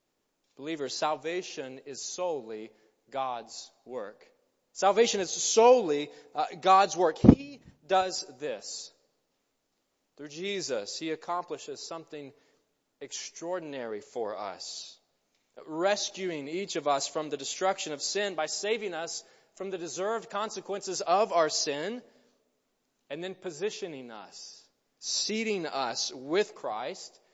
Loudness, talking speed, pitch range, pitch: -30 LUFS, 110 wpm, 155-210 Hz, 185 Hz